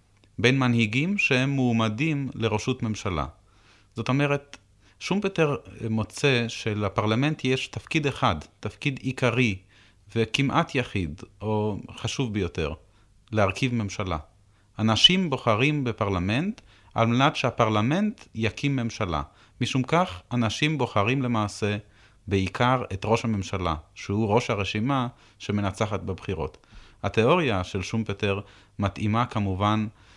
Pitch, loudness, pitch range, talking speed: 110 Hz, -25 LUFS, 100-130 Hz, 100 wpm